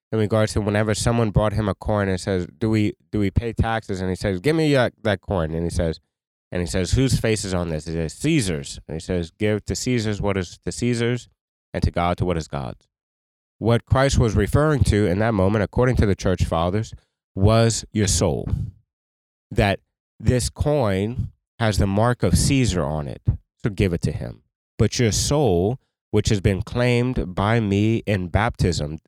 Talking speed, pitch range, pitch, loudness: 200 wpm, 90-115 Hz, 105 Hz, -22 LUFS